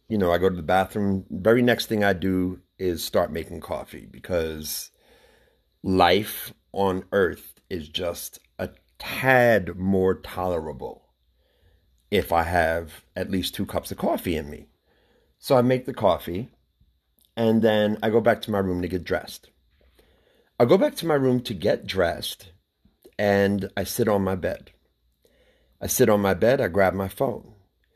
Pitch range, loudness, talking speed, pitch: 85-105 Hz, -24 LUFS, 165 wpm, 95 Hz